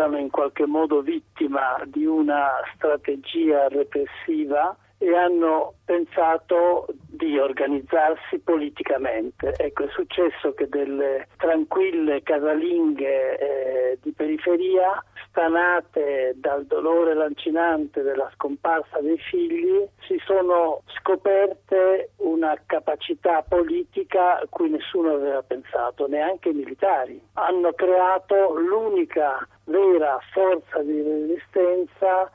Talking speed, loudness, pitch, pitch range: 100 wpm, -23 LUFS, 170 Hz, 150-205 Hz